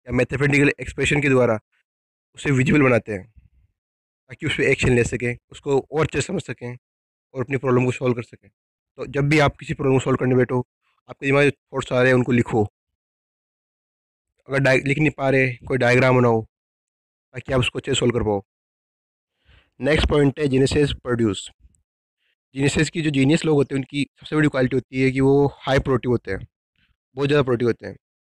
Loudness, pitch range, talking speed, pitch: -20 LUFS, 115-140 Hz, 195 wpm, 130 Hz